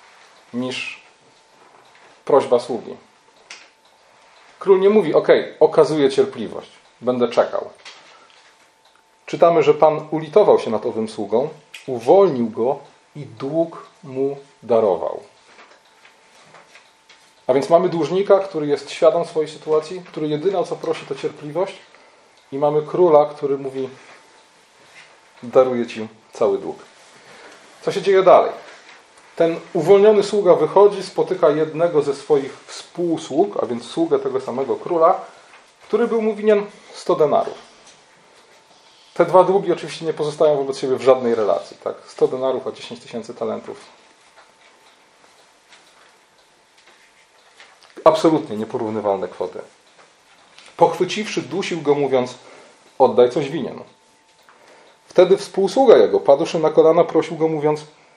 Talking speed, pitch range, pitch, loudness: 115 wpm, 150-220 Hz, 170 Hz, -18 LUFS